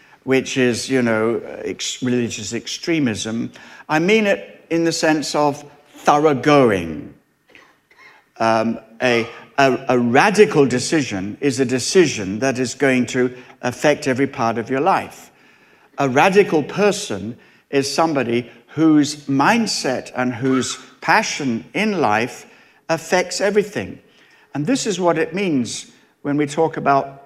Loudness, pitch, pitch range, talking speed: -18 LUFS, 140 Hz, 125-160 Hz, 130 wpm